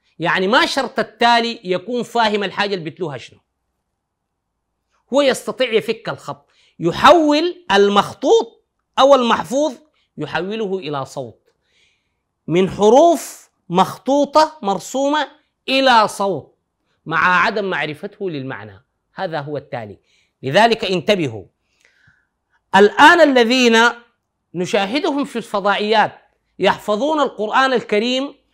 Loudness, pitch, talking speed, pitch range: -16 LUFS, 210 Hz, 95 wpm, 160-260 Hz